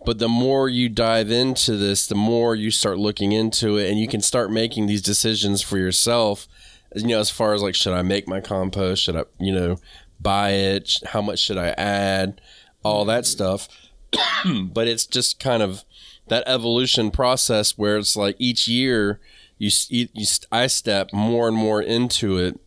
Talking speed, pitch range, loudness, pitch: 185 wpm, 100-115 Hz, -20 LUFS, 105 Hz